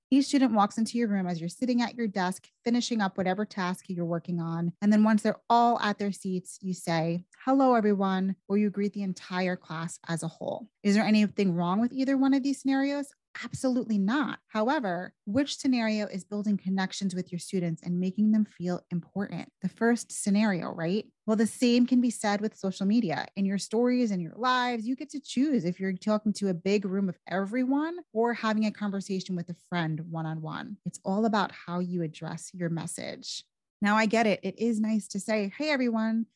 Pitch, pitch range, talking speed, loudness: 205 Hz, 180-235 Hz, 210 wpm, -29 LUFS